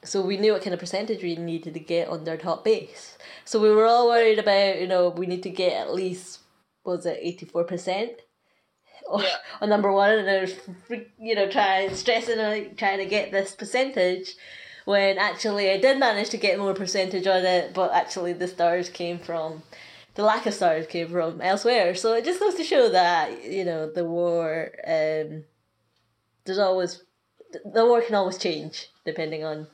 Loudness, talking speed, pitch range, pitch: -24 LUFS, 190 wpm, 170-215 Hz, 190 Hz